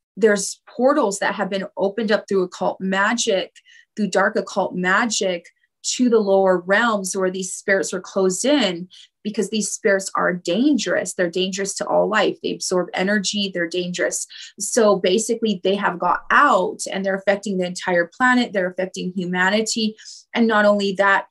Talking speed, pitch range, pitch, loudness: 165 wpm, 190-215 Hz, 195 Hz, -20 LUFS